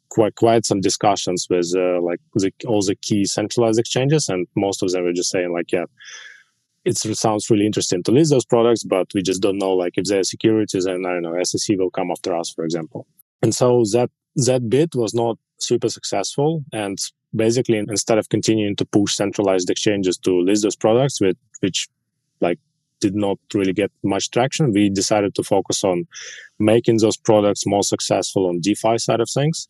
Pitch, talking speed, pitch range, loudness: 105 Hz, 195 wpm, 95-115 Hz, -19 LUFS